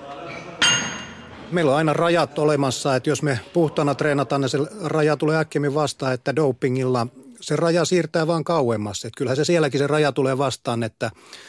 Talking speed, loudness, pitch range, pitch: 165 wpm, -21 LUFS, 135-155 Hz, 145 Hz